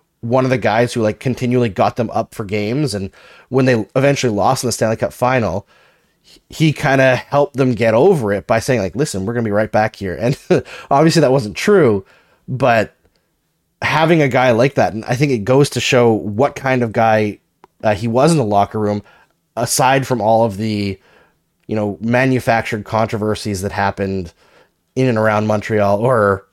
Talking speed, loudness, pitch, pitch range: 190 wpm, -16 LUFS, 115 Hz, 105-130 Hz